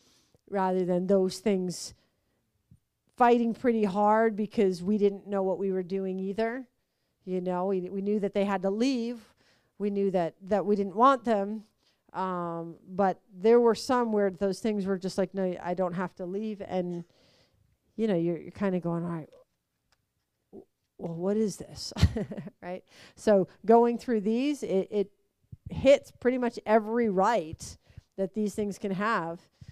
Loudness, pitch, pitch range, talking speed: -28 LUFS, 200 Hz, 185-220 Hz, 165 wpm